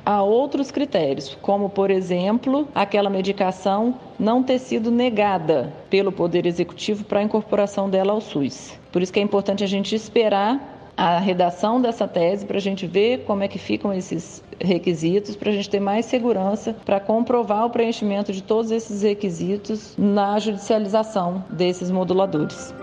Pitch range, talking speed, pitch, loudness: 190-220 Hz, 160 wpm, 205 Hz, -21 LUFS